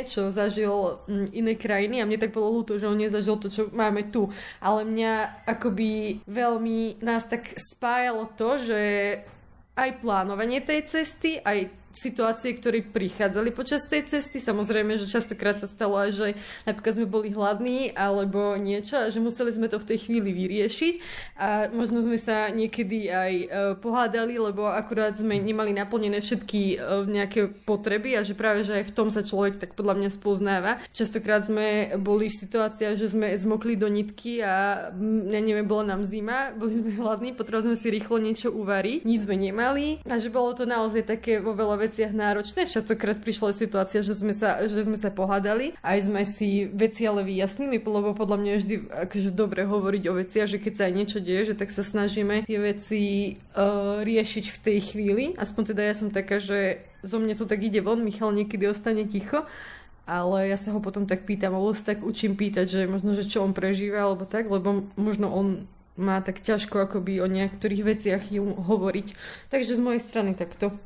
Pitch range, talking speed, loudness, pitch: 200-225 Hz, 185 wpm, -26 LUFS, 210 Hz